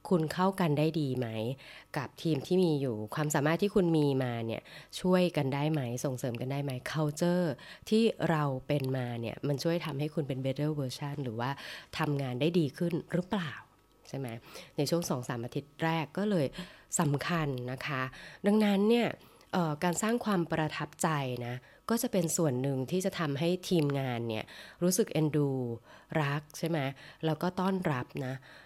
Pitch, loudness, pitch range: 150 Hz, -32 LUFS, 135-175 Hz